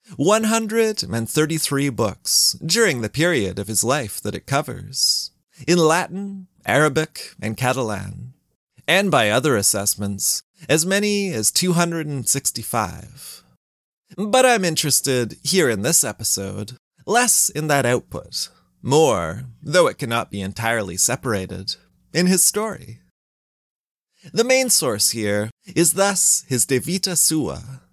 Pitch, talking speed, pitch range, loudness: 140 Hz, 120 wpm, 110-180 Hz, -19 LUFS